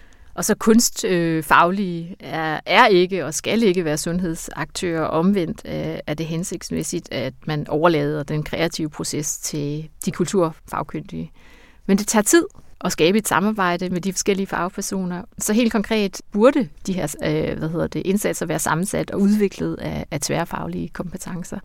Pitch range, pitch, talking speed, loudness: 155-200 Hz, 175 Hz, 150 wpm, -21 LUFS